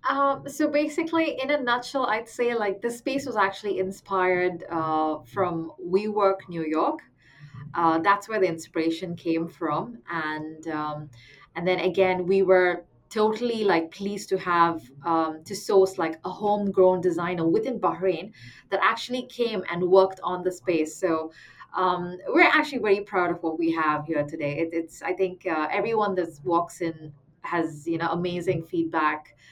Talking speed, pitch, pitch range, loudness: 165 wpm, 180 Hz, 165-200 Hz, -25 LUFS